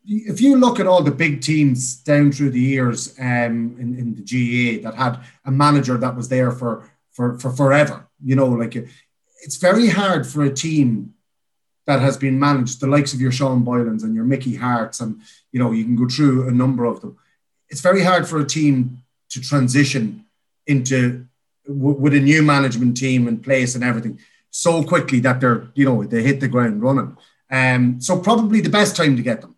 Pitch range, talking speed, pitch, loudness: 125-145 Hz, 205 wpm, 130 Hz, -18 LUFS